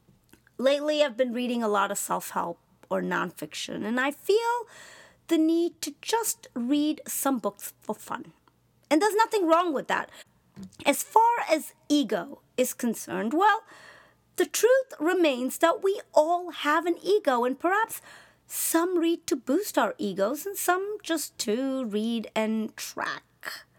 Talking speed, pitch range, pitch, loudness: 150 wpm, 255-360 Hz, 305 Hz, -27 LUFS